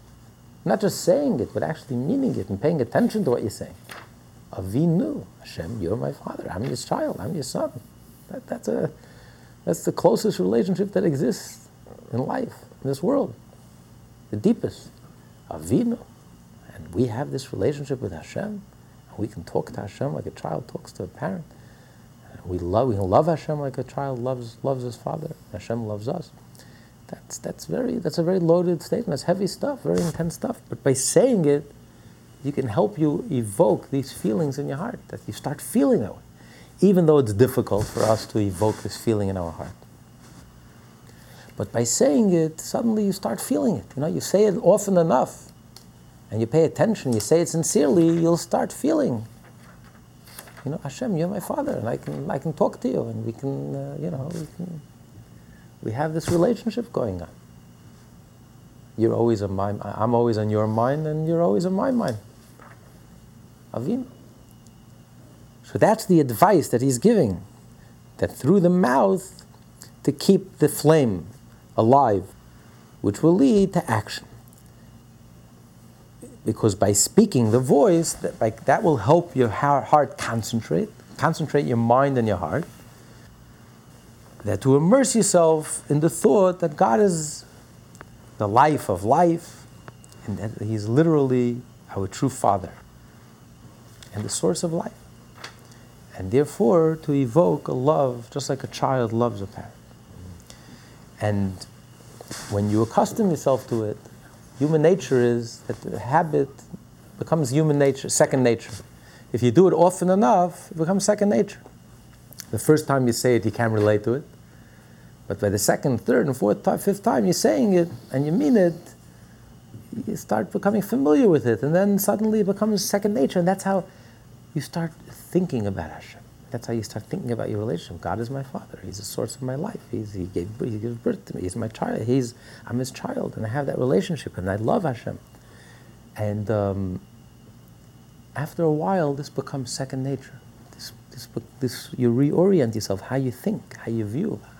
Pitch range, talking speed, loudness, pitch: 110-170 Hz, 170 wpm, -23 LUFS, 130 Hz